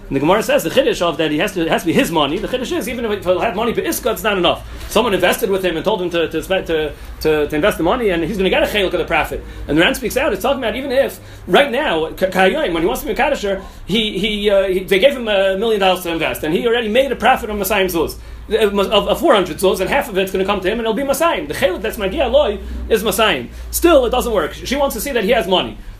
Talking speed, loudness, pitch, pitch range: 300 wpm, -16 LUFS, 200 Hz, 180-235 Hz